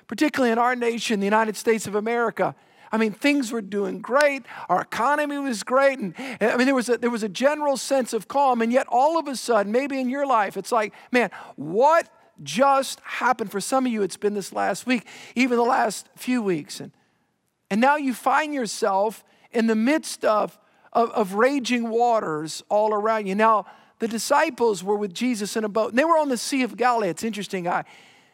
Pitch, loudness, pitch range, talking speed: 235 Hz, -23 LUFS, 215-265 Hz, 210 wpm